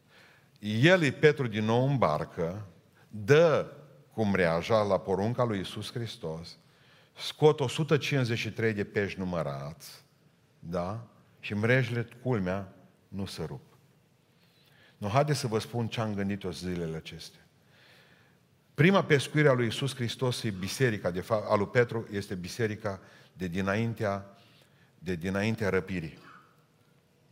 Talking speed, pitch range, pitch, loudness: 125 wpm, 100-140 Hz, 115 Hz, -29 LUFS